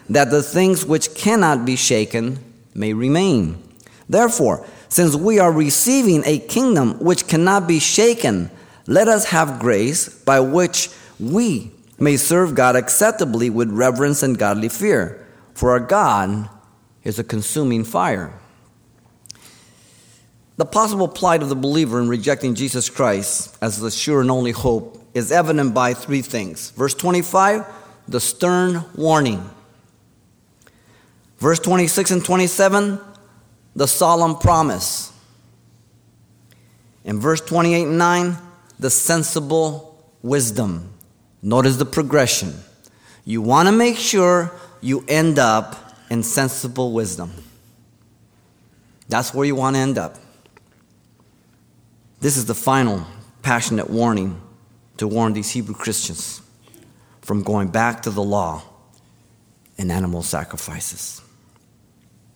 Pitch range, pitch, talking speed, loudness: 115-165 Hz, 130 Hz, 120 wpm, -18 LUFS